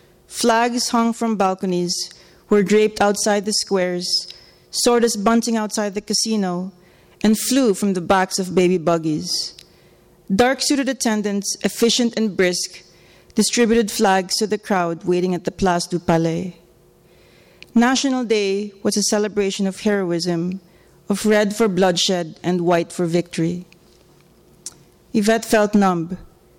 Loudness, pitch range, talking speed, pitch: -19 LUFS, 180-220 Hz, 125 wpm, 200 Hz